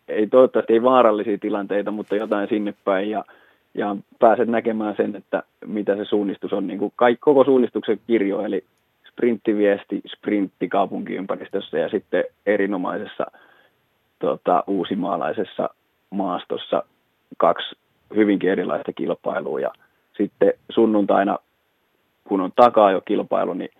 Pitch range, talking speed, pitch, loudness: 105-130 Hz, 120 wpm, 110 Hz, -21 LUFS